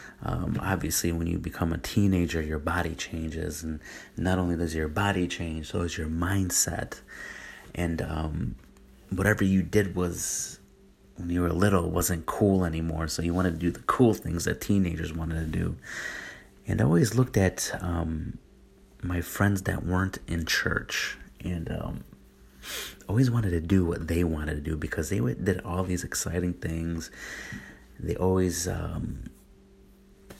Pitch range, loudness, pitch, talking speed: 80-90 Hz, -28 LUFS, 85 Hz, 160 wpm